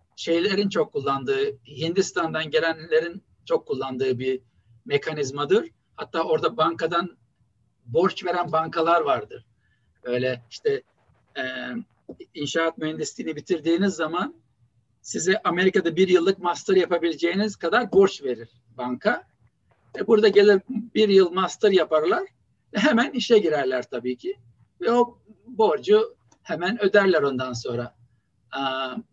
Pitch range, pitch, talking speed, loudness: 130-215 Hz, 170 Hz, 105 wpm, -23 LUFS